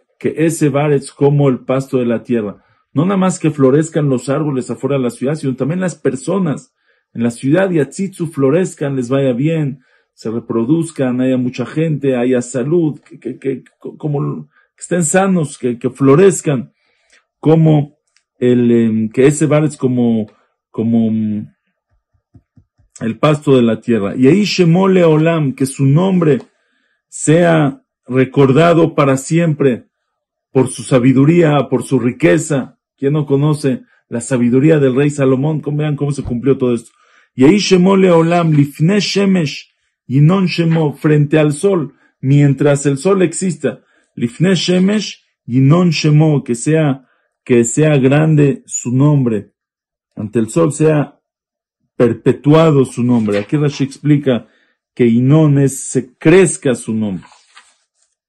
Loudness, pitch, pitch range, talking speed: -14 LUFS, 140 Hz, 130-160 Hz, 140 wpm